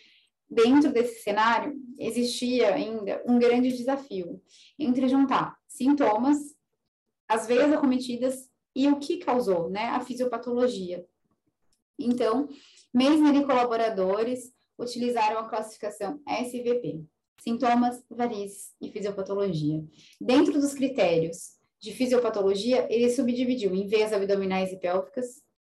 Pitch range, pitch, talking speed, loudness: 210-260 Hz, 245 Hz, 105 wpm, -26 LUFS